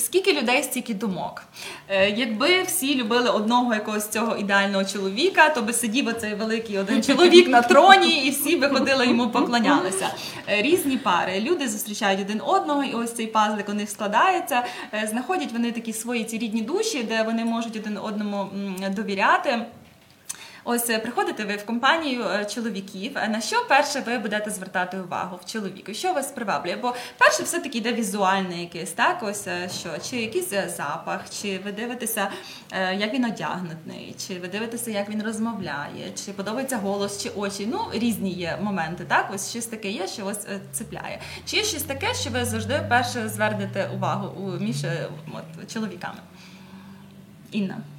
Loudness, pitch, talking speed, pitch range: -23 LUFS, 220 Hz, 160 wpm, 195-245 Hz